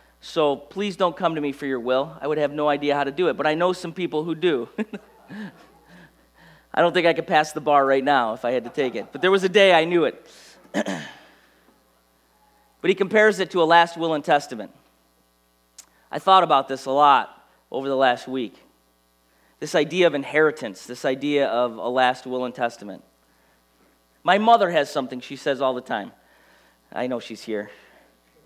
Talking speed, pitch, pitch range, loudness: 200 wpm, 140 Hz, 105-170 Hz, -21 LUFS